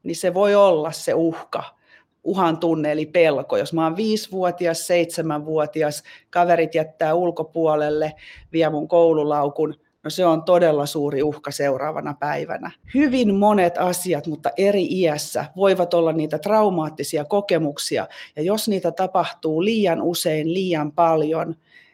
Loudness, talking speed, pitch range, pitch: -21 LUFS, 130 wpm, 155-180 Hz, 165 Hz